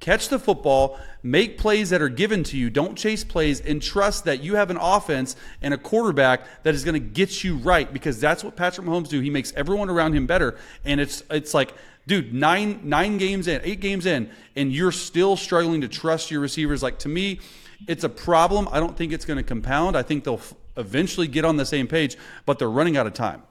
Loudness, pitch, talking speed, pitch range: -23 LUFS, 165 Hz, 230 wpm, 145-190 Hz